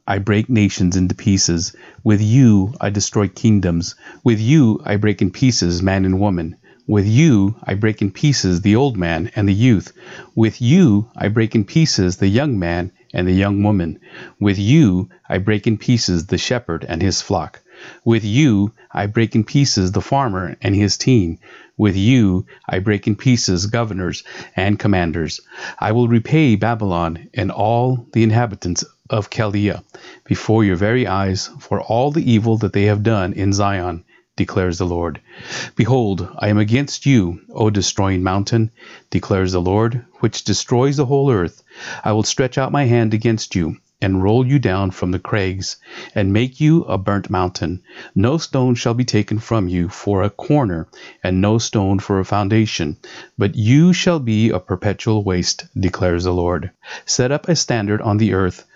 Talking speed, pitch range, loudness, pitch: 175 wpm, 95-120 Hz, -17 LUFS, 105 Hz